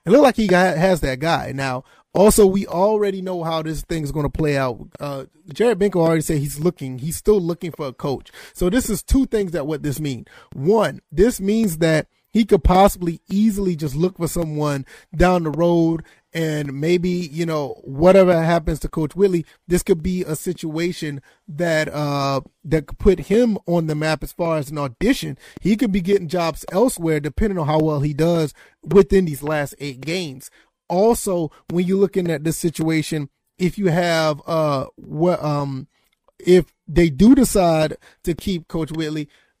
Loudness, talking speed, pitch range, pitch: -19 LUFS, 190 wpm, 155-190 Hz, 165 Hz